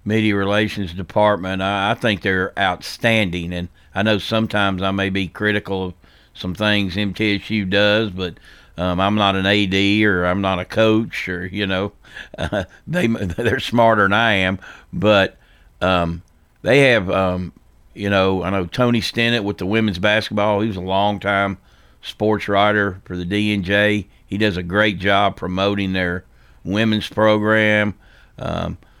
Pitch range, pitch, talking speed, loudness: 95-105 Hz, 100 Hz, 155 wpm, -18 LUFS